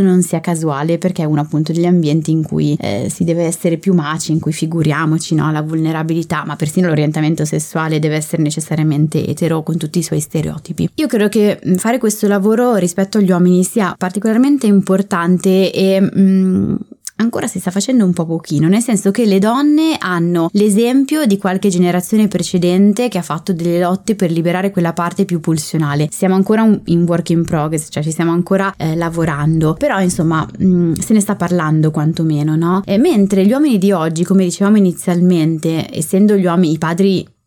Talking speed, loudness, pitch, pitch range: 185 wpm, -14 LUFS, 175 Hz, 160-195 Hz